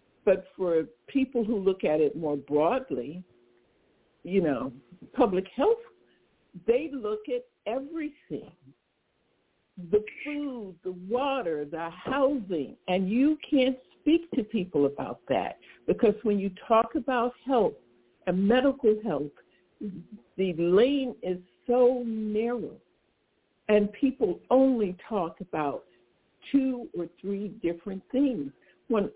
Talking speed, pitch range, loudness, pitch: 115 wpm, 180-255 Hz, -28 LUFS, 210 Hz